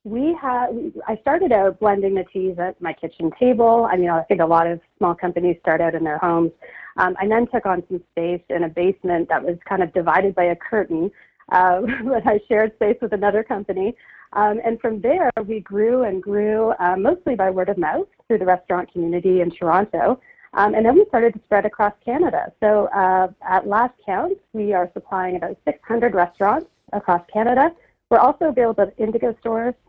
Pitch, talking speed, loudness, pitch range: 200 Hz, 200 wpm, -20 LUFS, 180-230 Hz